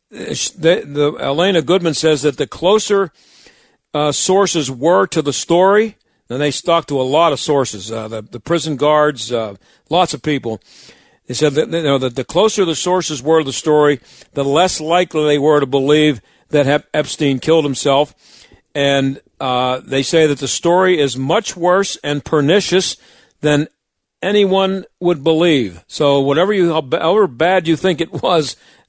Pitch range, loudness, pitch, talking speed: 140-170 Hz, -15 LUFS, 150 Hz, 170 wpm